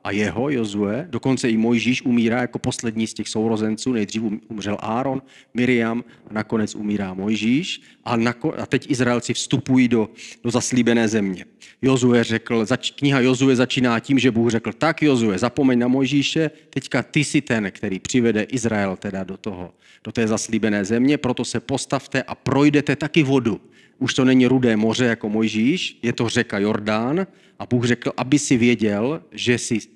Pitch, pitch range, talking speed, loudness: 120 Hz, 110-130 Hz, 165 wpm, -20 LUFS